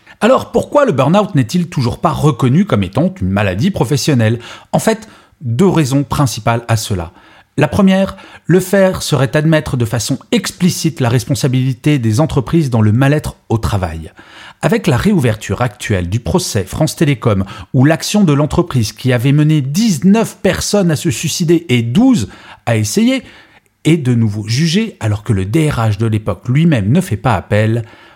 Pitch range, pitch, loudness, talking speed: 115-165 Hz, 140 Hz, -14 LUFS, 165 wpm